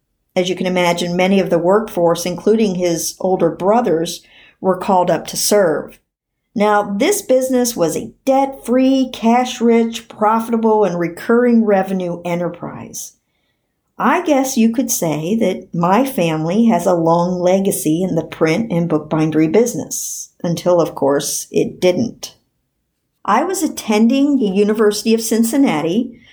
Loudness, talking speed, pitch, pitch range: -16 LUFS, 140 wpm, 195 Hz, 175-230 Hz